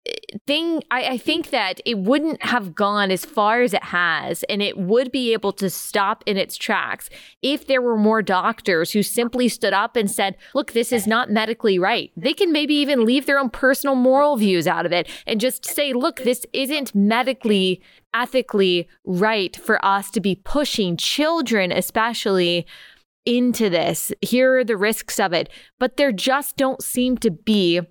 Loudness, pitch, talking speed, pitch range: -20 LUFS, 230 Hz, 185 wpm, 200-260 Hz